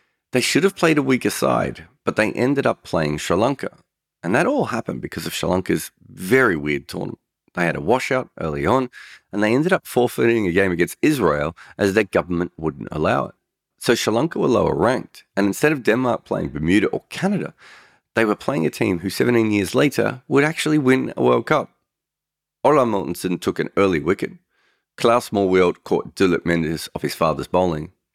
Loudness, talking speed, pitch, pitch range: -20 LUFS, 190 wpm, 100 Hz, 85-125 Hz